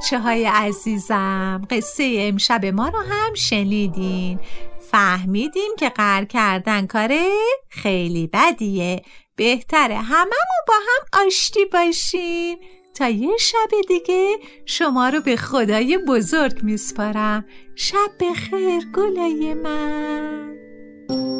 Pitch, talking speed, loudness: 250 Hz, 100 wpm, -19 LUFS